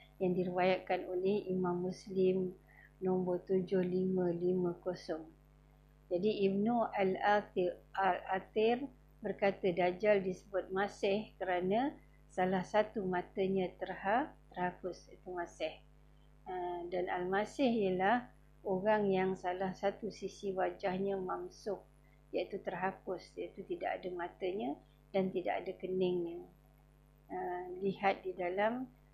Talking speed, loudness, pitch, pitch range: 95 wpm, -36 LUFS, 185 Hz, 180-200 Hz